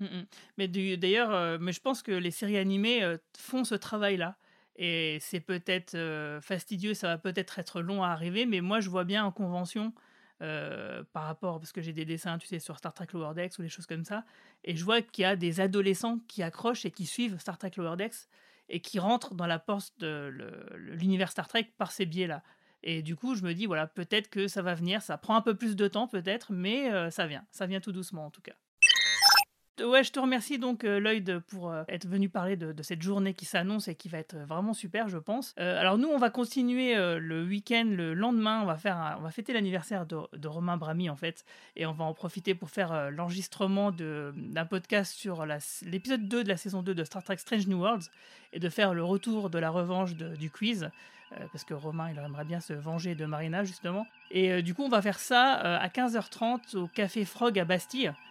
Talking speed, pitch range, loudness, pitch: 240 wpm, 170-215 Hz, -31 LUFS, 190 Hz